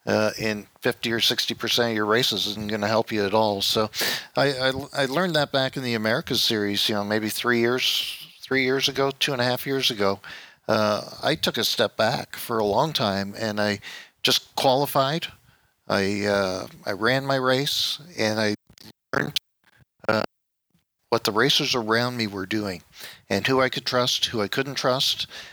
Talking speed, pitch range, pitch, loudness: 190 wpm, 105-130 Hz, 115 Hz, -23 LUFS